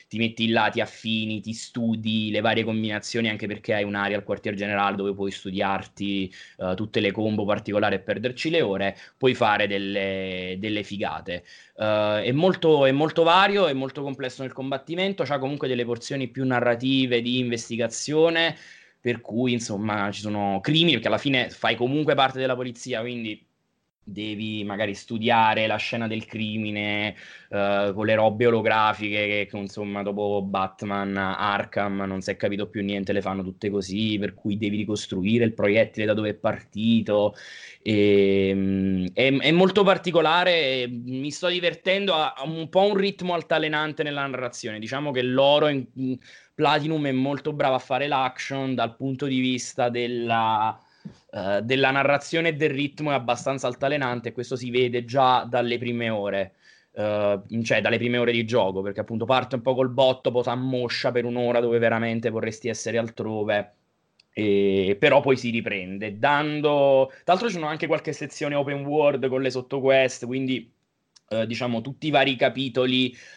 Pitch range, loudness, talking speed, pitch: 105-135 Hz, -24 LUFS, 165 wpm, 120 Hz